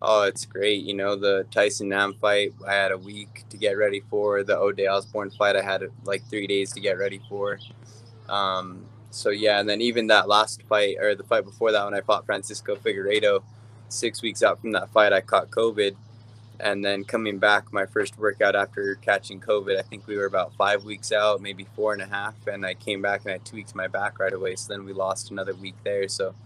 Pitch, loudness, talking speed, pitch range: 105 Hz, -24 LUFS, 230 wpm, 100-110 Hz